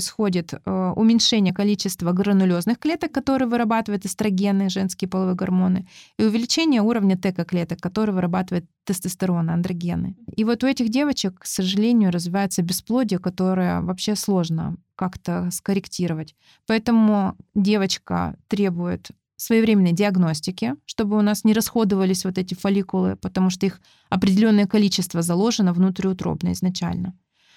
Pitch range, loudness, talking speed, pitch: 180-215 Hz, -21 LUFS, 120 wpm, 195 Hz